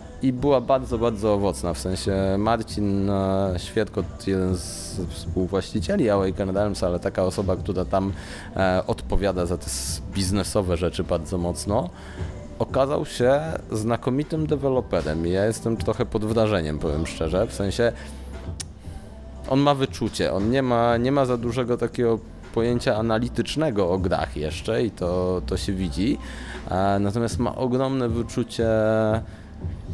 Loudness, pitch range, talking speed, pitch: -24 LUFS, 90-115 Hz, 130 wpm, 100 Hz